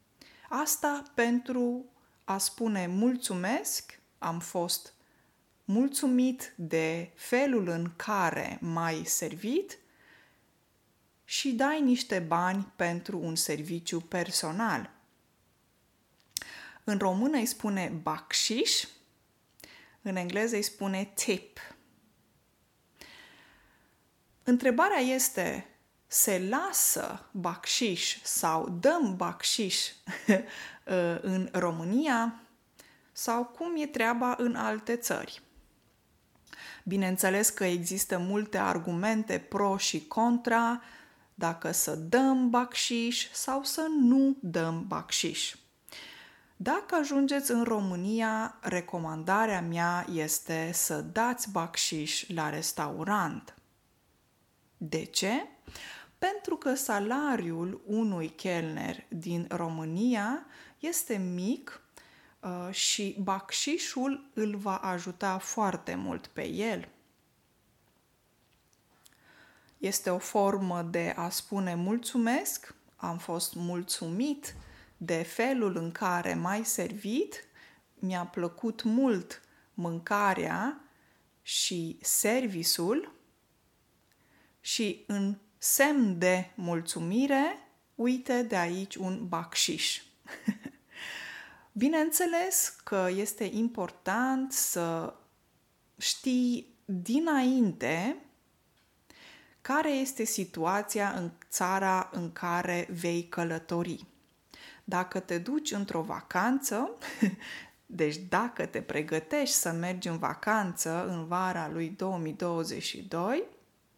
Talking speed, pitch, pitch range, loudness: 85 wpm, 200 Hz, 175-250 Hz, -30 LUFS